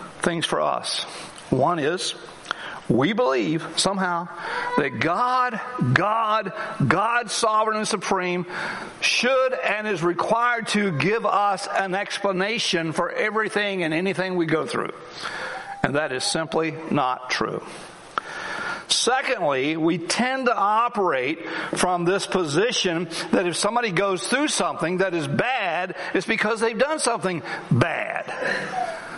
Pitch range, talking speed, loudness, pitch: 175-230 Hz, 125 wpm, -23 LUFS, 195 Hz